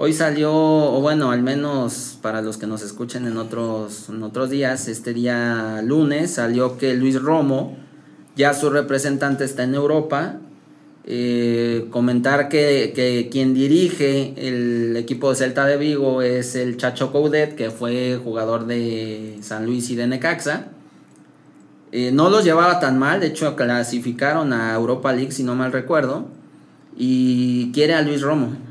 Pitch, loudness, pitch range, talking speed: 130 Hz, -20 LUFS, 120-145 Hz, 155 wpm